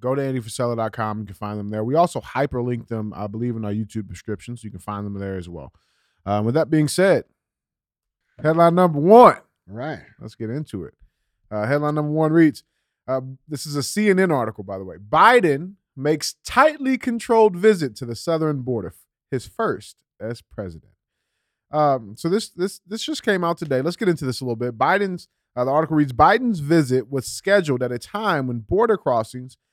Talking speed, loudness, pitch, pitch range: 200 wpm, -20 LUFS, 130 Hz, 110-170 Hz